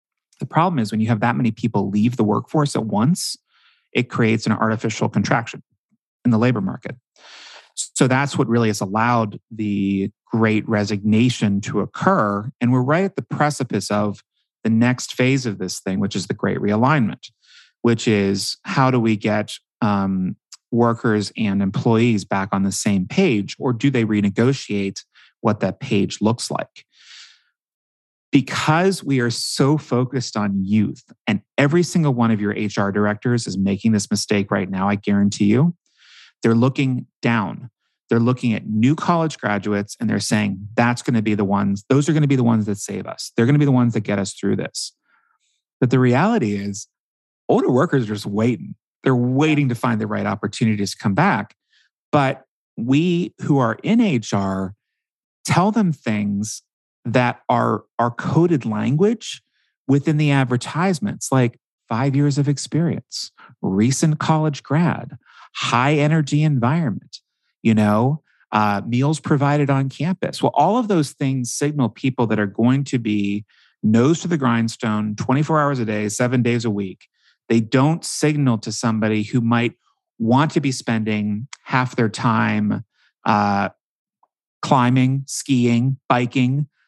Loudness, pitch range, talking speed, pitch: -20 LUFS, 105-140 Hz, 160 wpm, 120 Hz